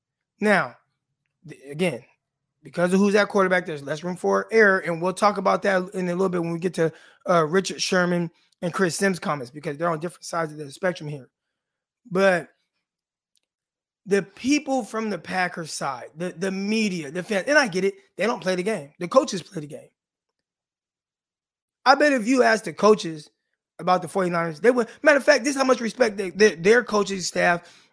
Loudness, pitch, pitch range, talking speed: -22 LUFS, 185 Hz, 165-205 Hz, 200 wpm